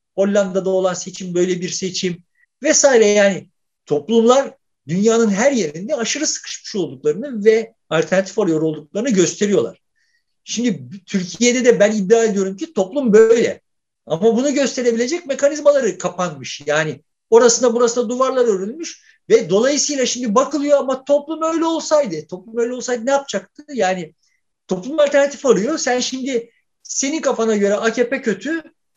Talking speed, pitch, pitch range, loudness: 130 wpm, 230 Hz, 190-275 Hz, -17 LUFS